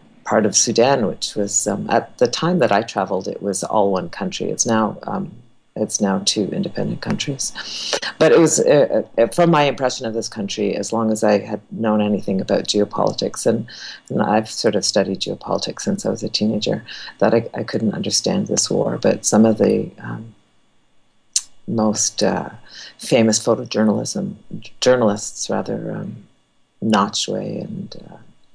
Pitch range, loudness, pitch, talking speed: 105-115 Hz, -19 LUFS, 110 Hz, 165 wpm